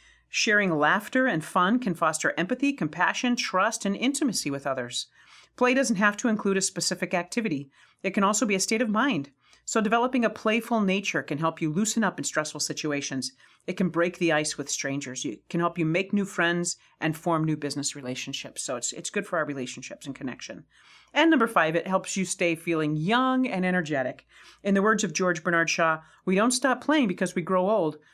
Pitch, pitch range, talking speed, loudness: 185 Hz, 155-220 Hz, 205 wpm, -26 LUFS